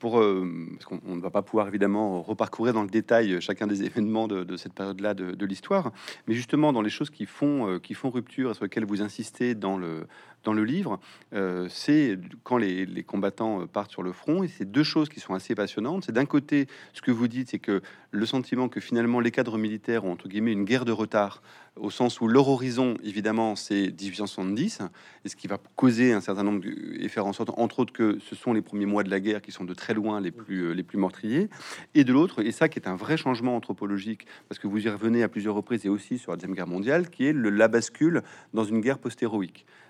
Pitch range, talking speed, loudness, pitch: 100-120 Hz, 240 wpm, -27 LUFS, 110 Hz